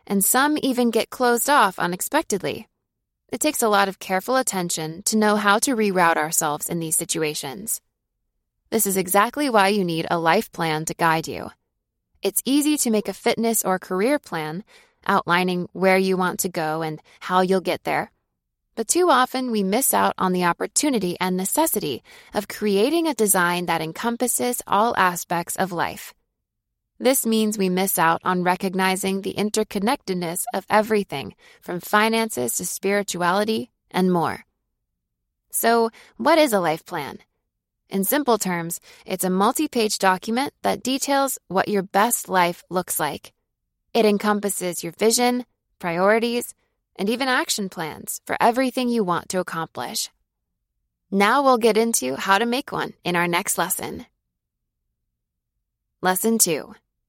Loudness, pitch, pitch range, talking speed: -21 LUFS, 195 Hz, 175-230 Hz, 150 wpm